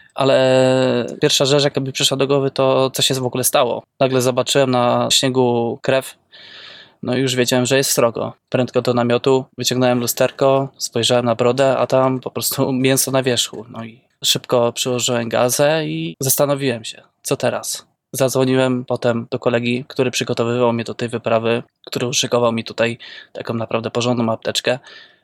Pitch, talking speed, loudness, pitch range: 125 Hz, 160 wpm, -17 LUFS, 120-135 Hz